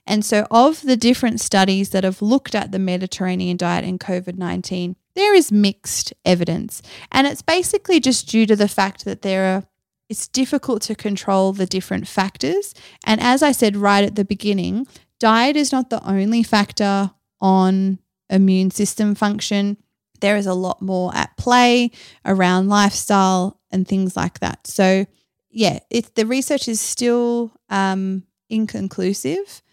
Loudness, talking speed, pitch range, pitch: -18 LUFS, 155 wpm, 190-235 Hz, 205 Hz